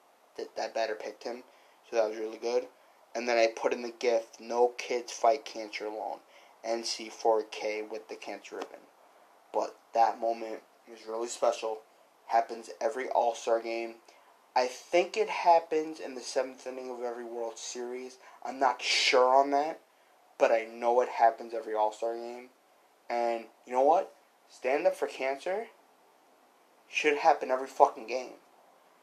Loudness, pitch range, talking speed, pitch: -30 LUFS, 115-130 Hz, 155 wpm, 115 Hz